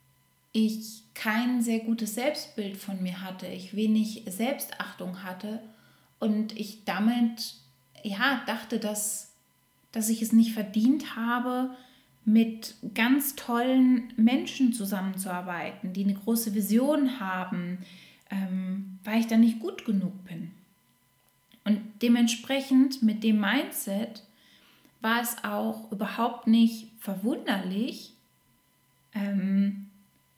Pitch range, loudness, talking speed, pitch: 200-235 Hz, -28 LUFS, 105 wpm, 220 Hz